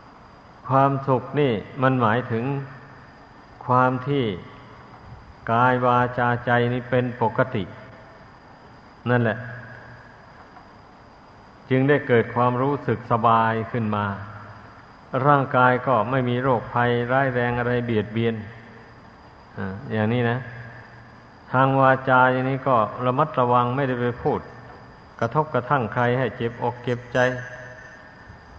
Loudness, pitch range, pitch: -22 LUFS, 115-130 Hz, 125 Hz